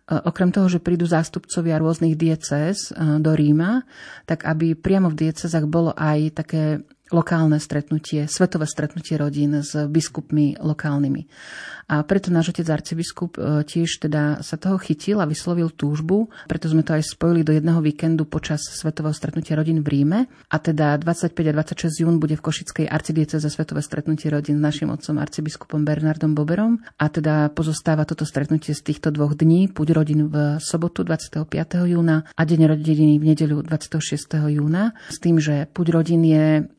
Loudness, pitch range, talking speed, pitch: -21 LUFS, 150-165 Hz, 165 wpm, 155 Hz